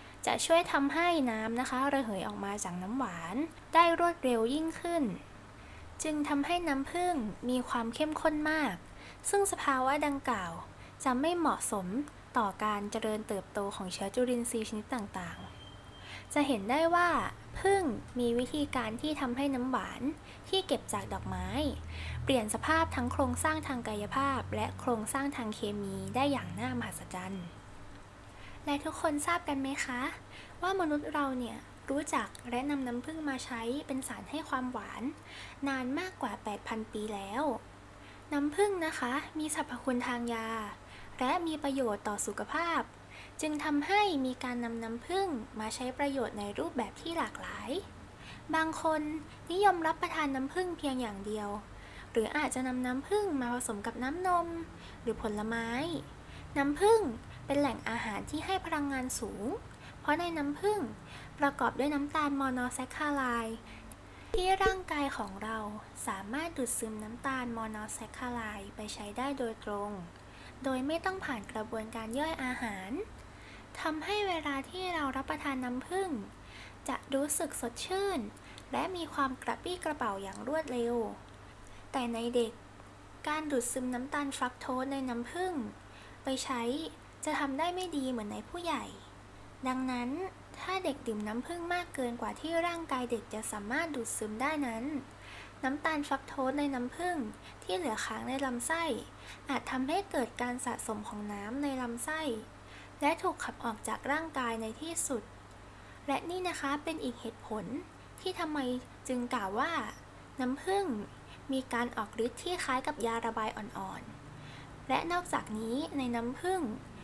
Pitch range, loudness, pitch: 230-310 Hz, -34 LUFS, 265 Hz